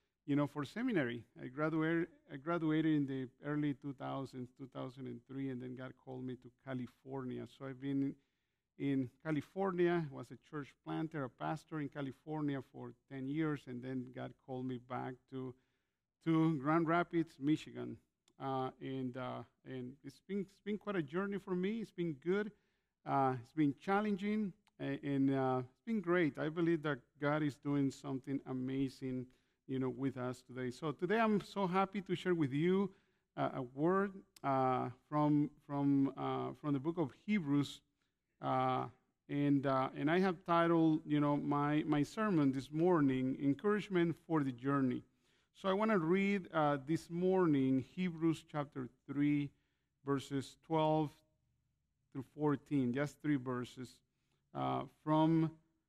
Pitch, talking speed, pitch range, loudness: 145 Hz, 155 wpm, 130-165 Hz, -38 LUFS